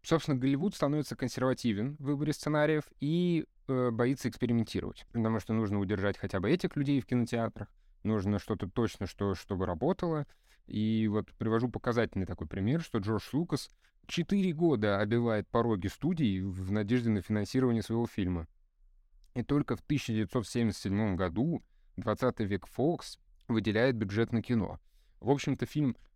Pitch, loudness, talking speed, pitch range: 115 Hz, -32 LUFS, 140 wpm, 105-130 Hz